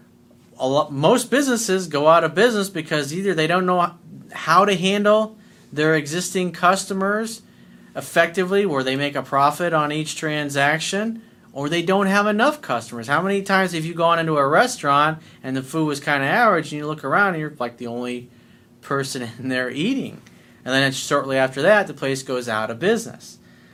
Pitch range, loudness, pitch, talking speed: 135-195 Hz, -20 LUFS, 160 Hz, 190 wpm